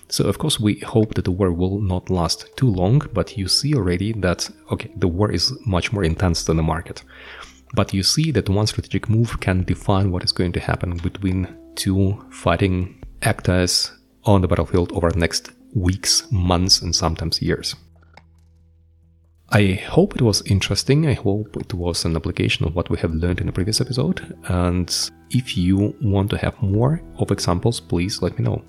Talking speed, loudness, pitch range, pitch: 190 wpm, -20 LUFS, 85-105 Hz, 95 Hz